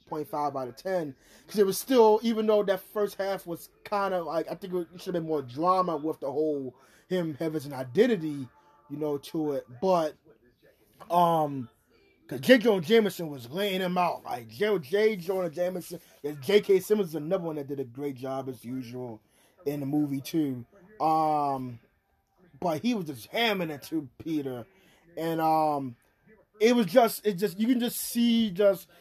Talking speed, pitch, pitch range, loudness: 180 wpm, 165 Hz, 145-200 Hz, -28 LUFS